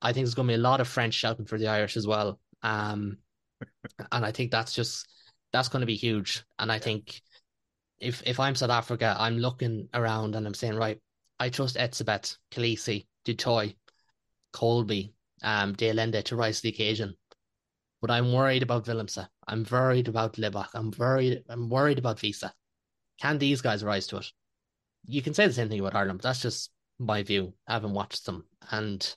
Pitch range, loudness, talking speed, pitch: 105-120 Hz, -29 LUFS, 195 wpm, 115 Hz